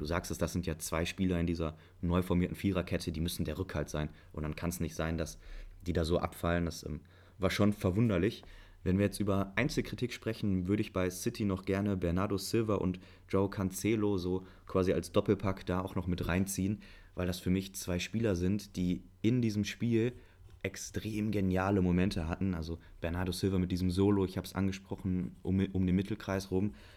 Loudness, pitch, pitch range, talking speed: -34 LUFS, 95 Hz, 90-100 Hz, 200 wpm